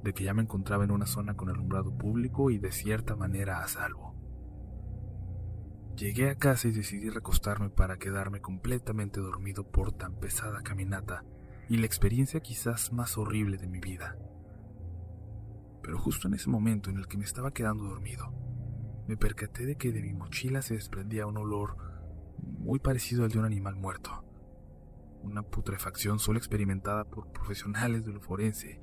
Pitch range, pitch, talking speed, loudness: 95-110 Hz, 105 Hz, 165 wpm, -33 LUFS